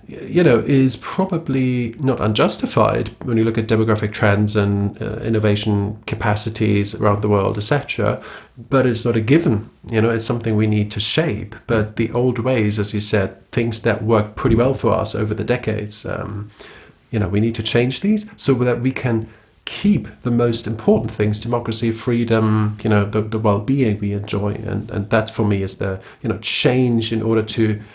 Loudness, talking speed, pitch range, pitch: -19 LUFS, 190 wpm, 105-120 Hz, 110 Hz